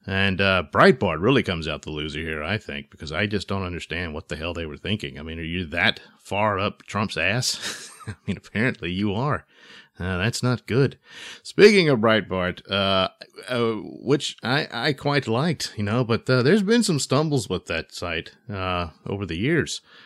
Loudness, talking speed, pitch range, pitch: -23 LUFS, 195 wpm, 85-120 Hz, 100 Hz